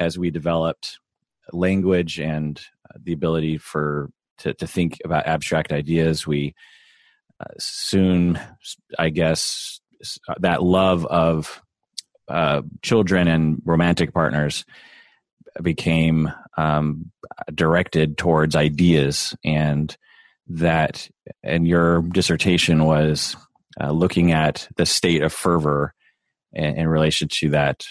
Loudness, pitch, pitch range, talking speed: -20 LUFS, 80 Hz, 75-85 Hz, 110 wpm